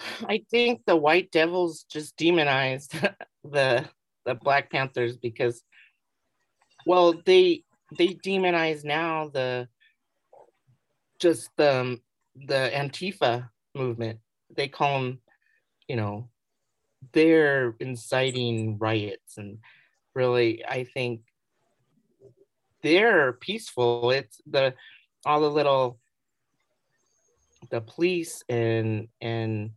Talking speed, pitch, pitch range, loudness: 95 wpm, 135 Hz, 120-160 Hz, -25 LUFS